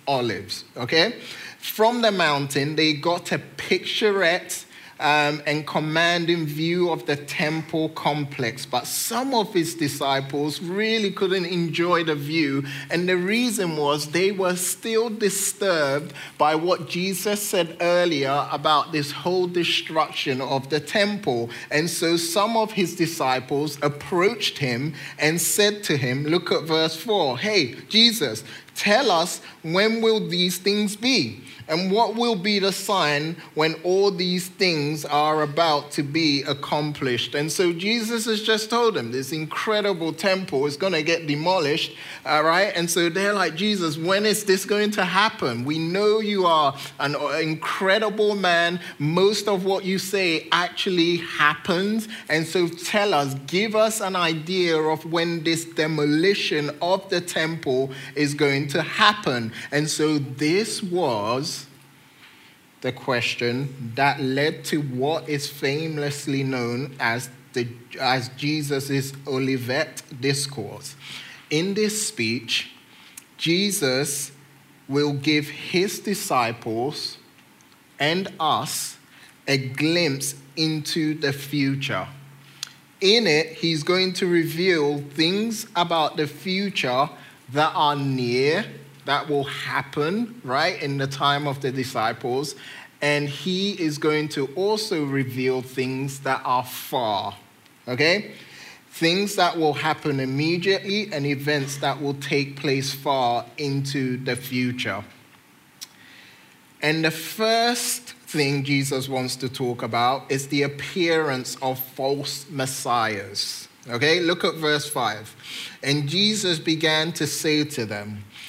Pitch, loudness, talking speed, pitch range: 155 Hz, -23 LUFS, 130 wpm, 140-180 Hz